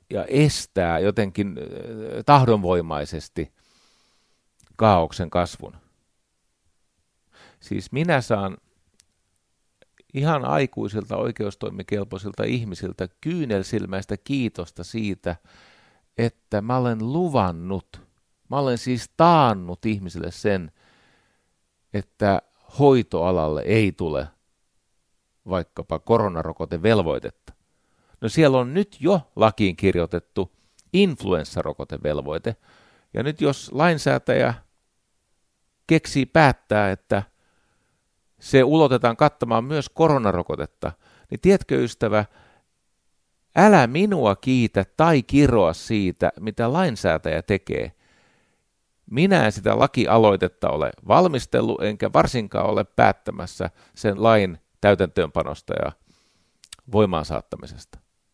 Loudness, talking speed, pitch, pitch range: -22 LUFS, 85 wpm, 105 Hz, 90-130 Hz